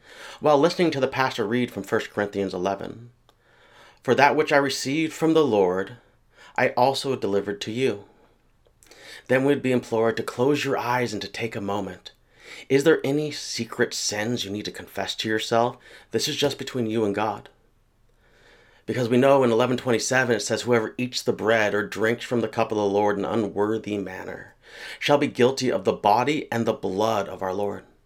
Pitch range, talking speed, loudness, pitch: 105-135 Hz, 195 wpm, -24 LUFS, 120 Hz